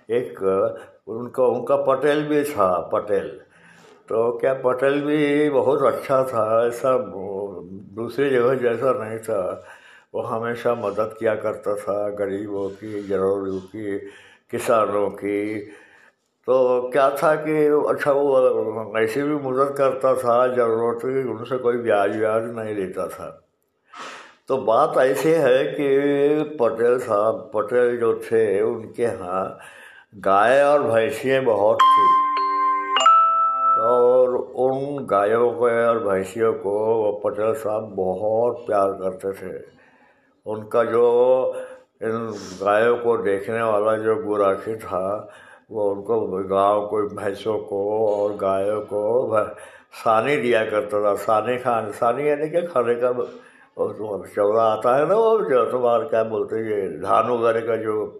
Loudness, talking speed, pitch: -21 LUFS, 130 wpm, 130 Hz